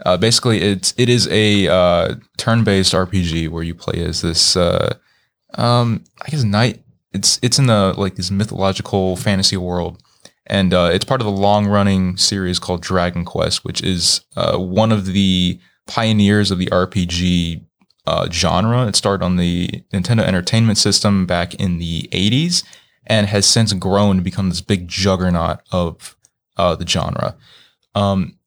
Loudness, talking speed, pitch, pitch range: -16 LUFS, 160 wpm, 95 Hz, 90-105 Hz